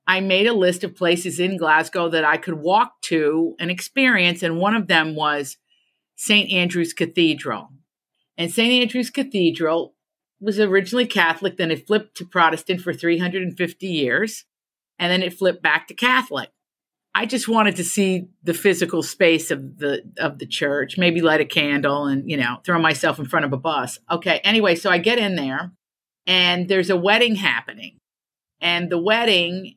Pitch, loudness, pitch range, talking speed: 175 Hz, -19 LUFS, 160-195 Hz, 175 wpm